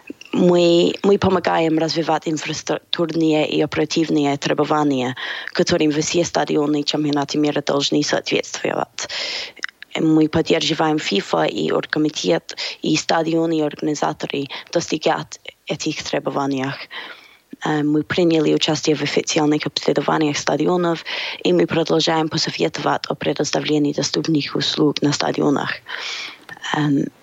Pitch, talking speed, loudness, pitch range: 155 Hz, 105 wpm, -19 LUFS, 150-165 Hz